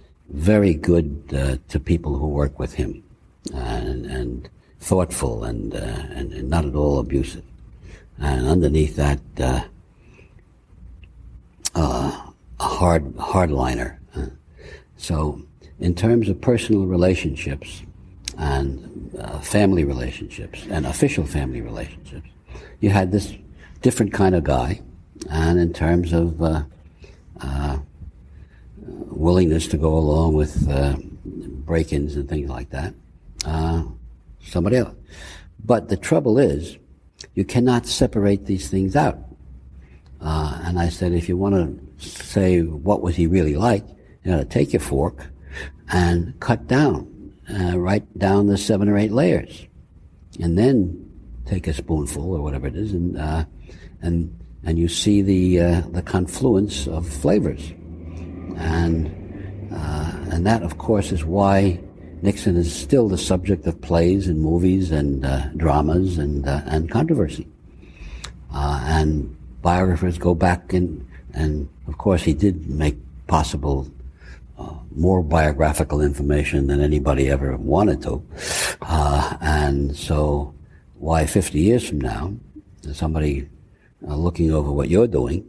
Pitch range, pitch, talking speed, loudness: 75-90 Hz, 80 Hz, 135 wpm, -21 LUFS